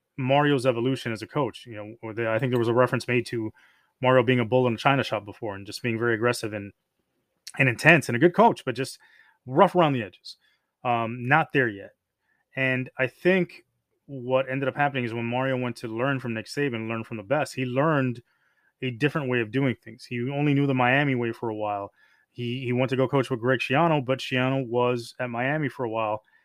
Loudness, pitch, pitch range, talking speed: -25 LUFS, 125 Hz, 115-135 Hz, 225 wpm